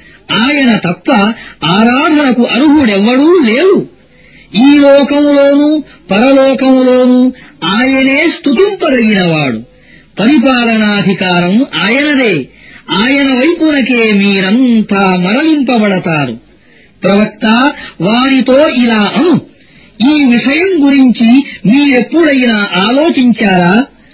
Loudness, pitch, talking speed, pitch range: -8 LUFS, 250 Hz, 60 wpm, 205-280 Hz